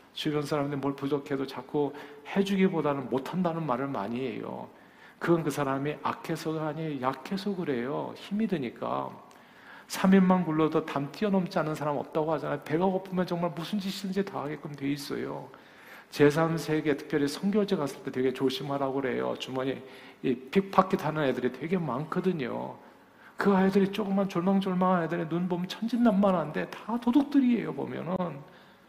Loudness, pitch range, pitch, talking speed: -29 LUFS, 140-190 Hz, 160 Hz, 350 characters per minute